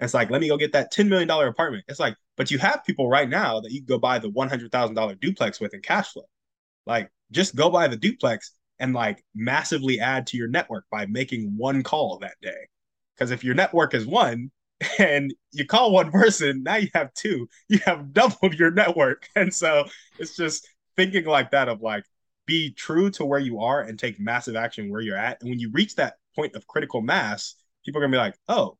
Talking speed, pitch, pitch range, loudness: 225 wpm, 140 Hz, 120-175 Hz, -23 LUFS